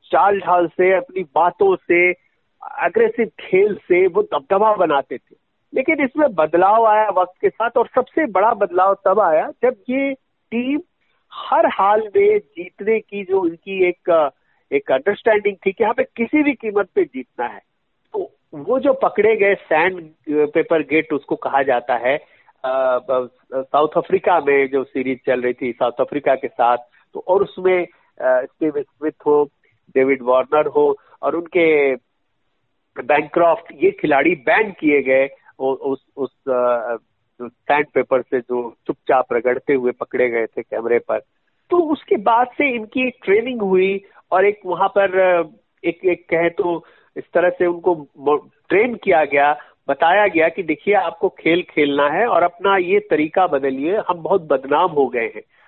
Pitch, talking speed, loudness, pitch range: 180 Hz, 155 wpm, -18 LUFS, 145-220 Hz